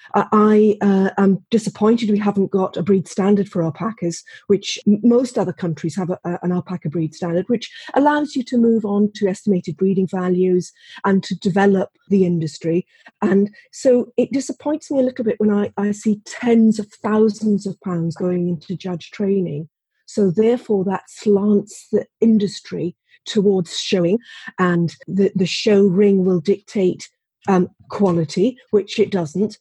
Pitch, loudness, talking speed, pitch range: 200 Hz, -19 LUFS, 160 wpm, 180-215 Hz